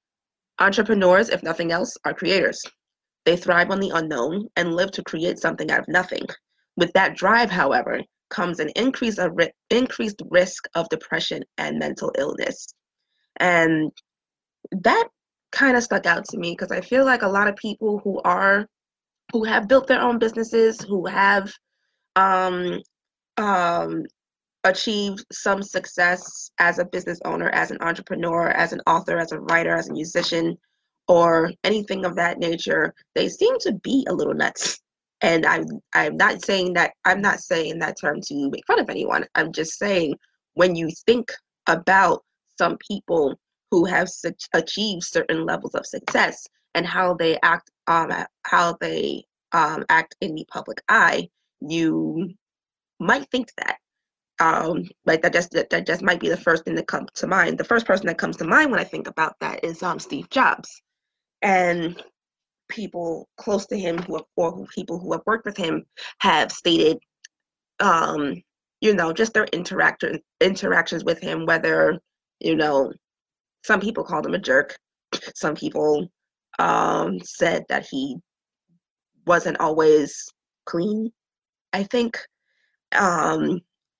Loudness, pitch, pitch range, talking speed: -21 LUFS, 190 Hz, 170-225 Hz, 160 wpm